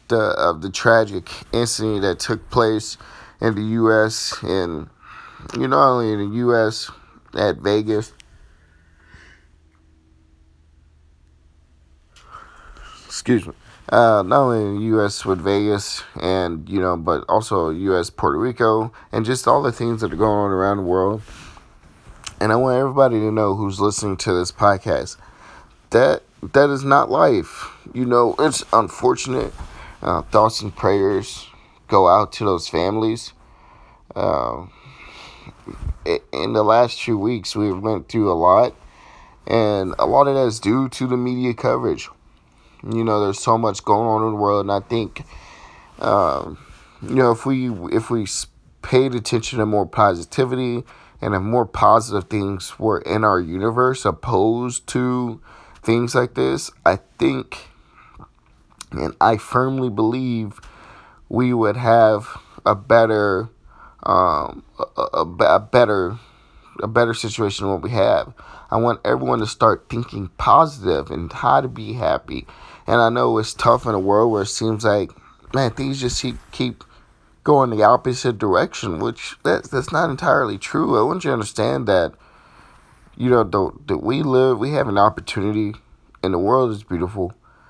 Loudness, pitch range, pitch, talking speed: -19 LUFS, 100-120 Hz, 110 Hz, 155 wpm